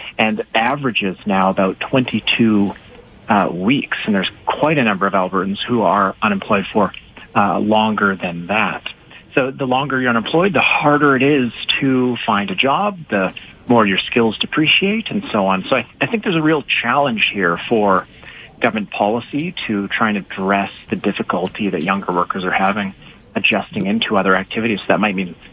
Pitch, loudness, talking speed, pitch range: 115 Hz, -17 LUFS, 175 wpm, 100-140 Hz